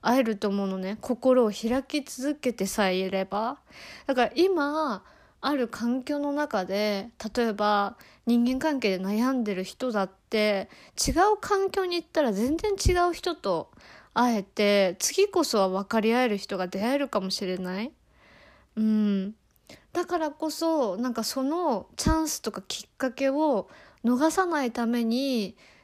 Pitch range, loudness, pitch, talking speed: 205-295 Hz, -27 LUFS, 240 Hz, 270 characters per minute